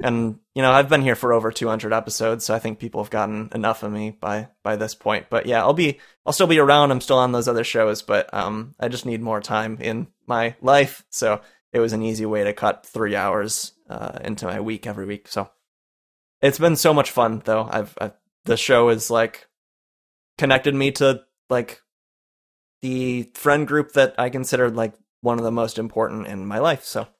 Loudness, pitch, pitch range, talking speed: -21 LUFS, 115 Hz, 110-130 Hz, 210 wpm